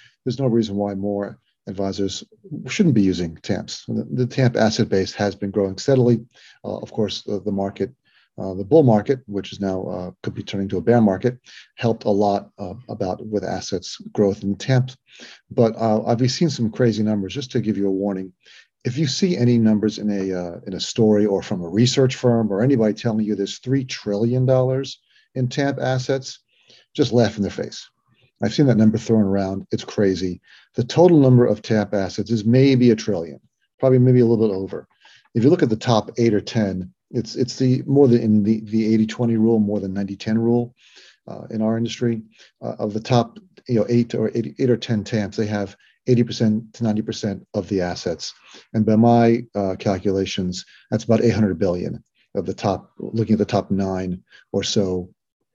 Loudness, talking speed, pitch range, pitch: -20 LUFS, 200 wpm, 100-120 Hz, 110 Hz